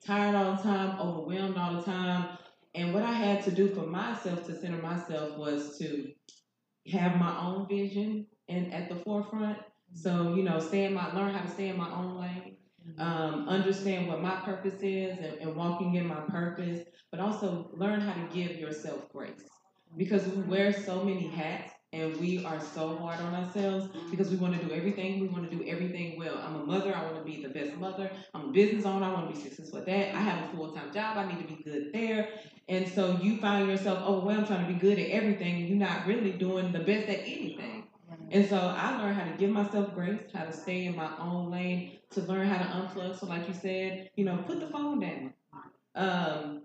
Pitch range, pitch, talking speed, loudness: 170-195 Hz, 185 Hz, 225 wpm, -32 LUFS